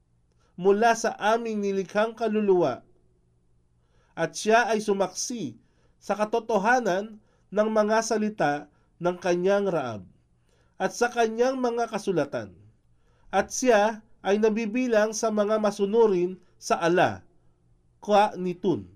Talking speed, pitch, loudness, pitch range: 105 wpm, 200 Hz, -25 LUFS, 160-220 Hz